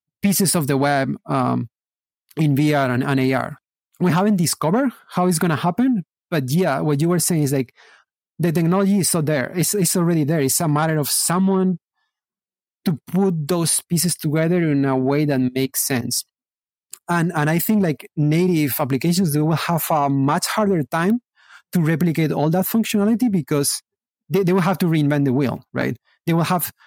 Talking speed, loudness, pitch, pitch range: 185 wpm, -19 LUFS, 165 Hz, 145-185 Hz